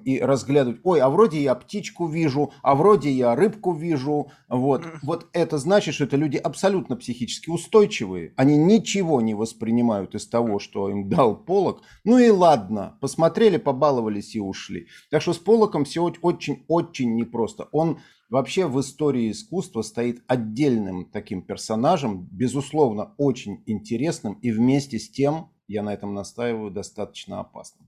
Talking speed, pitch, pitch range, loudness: 150 wpm, 140 Hz, 115-170 Hz, -22 LUFS